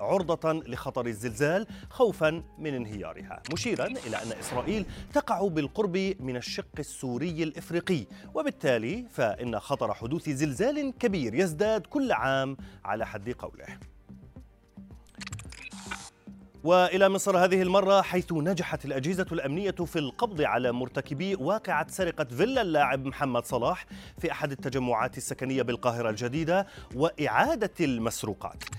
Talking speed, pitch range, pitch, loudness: 115 wpm, 125-190 Hz, 155 Hz, -29 LUFS